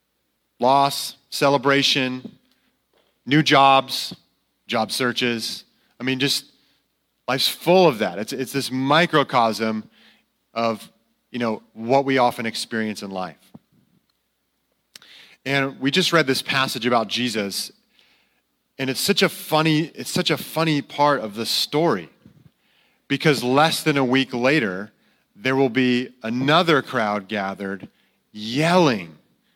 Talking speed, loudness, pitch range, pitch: 120 wpm, -20 LUFS, 115-145 Hz, 135 Hz